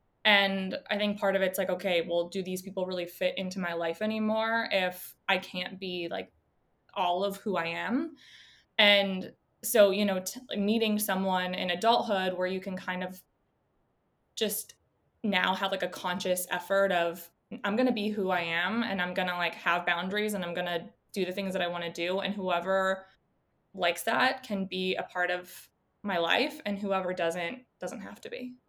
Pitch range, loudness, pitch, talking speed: 180-205 Hz, -29 LUFS, 190 Hz, 200 wpm